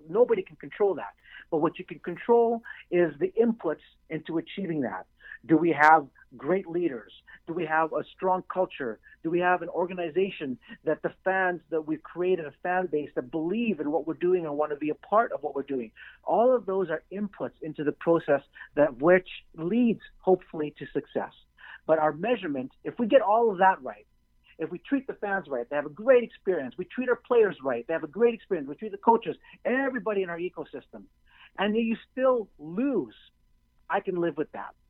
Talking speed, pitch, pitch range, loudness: 205 wpm, 175 Hz, 155-215 Hz, -27 LUFS